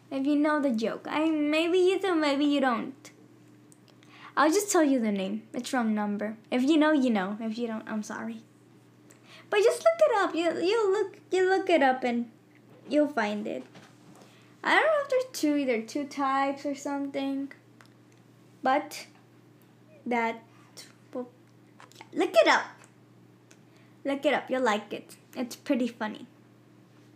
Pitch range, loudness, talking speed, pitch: 225-310 Hz, -27 LUFS, 165 wpm, 275 Hz